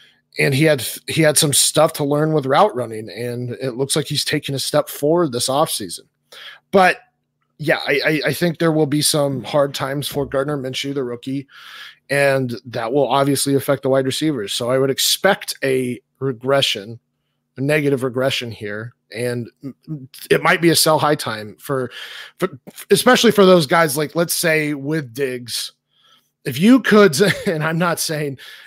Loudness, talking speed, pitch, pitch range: -17 LUFS, 175 wpm, 140 Hz, 130-155 Hz